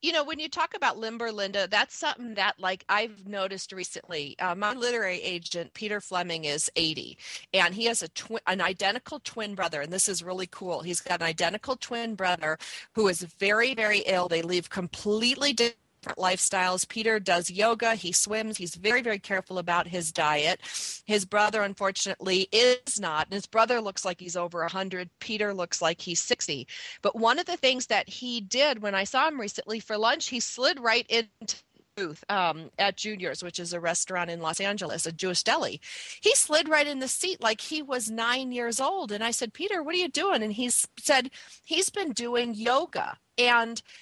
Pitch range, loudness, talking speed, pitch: 180-240 Hz, -27 LUFS, 200 wpm, 210 Hz